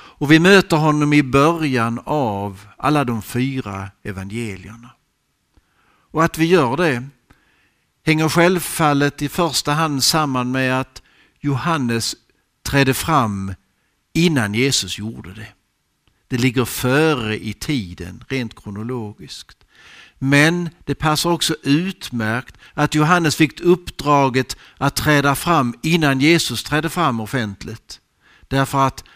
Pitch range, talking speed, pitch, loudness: 115-155 Hz, 115 wpm, 135 Hz, -18 LUFS